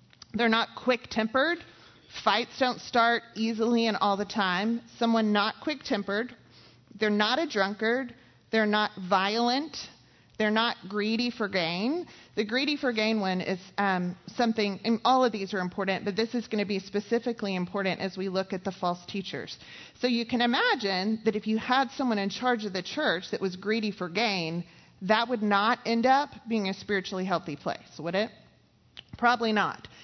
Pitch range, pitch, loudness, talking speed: 195-235 Hz, 215 Hz, -28 LUFS, 175 wpm